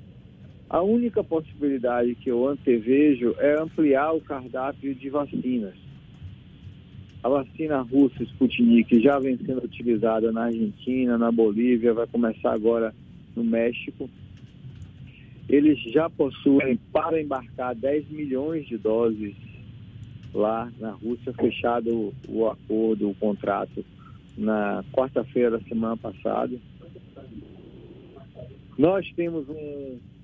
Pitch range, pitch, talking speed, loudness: 115-140 Hz, 120 Hz, 105 wpm, -24 LUFS